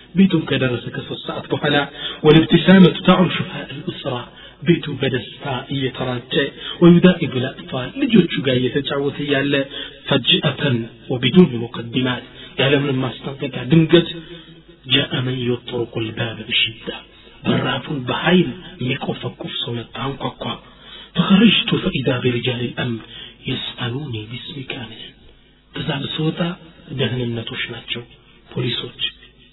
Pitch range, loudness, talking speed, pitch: 125-165 Hz, -19 LUFS, 100 wpm, 140 Hz